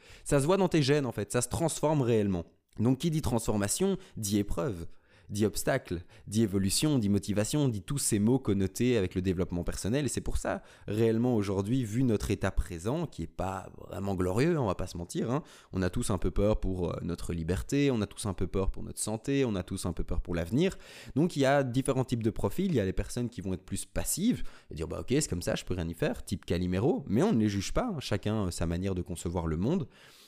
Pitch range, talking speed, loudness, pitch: 95-125 Hz, 250 wpm, -31 LUFS, 105 Hz